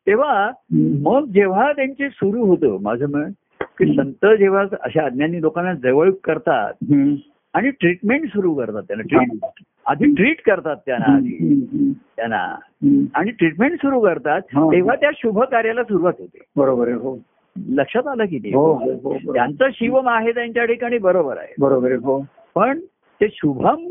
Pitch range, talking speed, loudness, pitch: 175-275 Hz, 125 wpm, -18 LUFS, 235 Hz